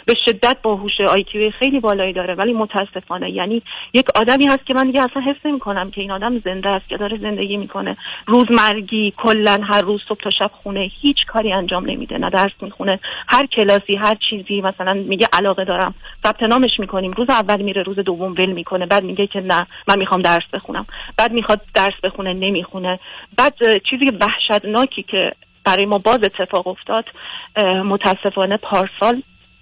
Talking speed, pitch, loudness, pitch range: 175 wpm, 205 Hz, -17 LUFS, 190-225 Hz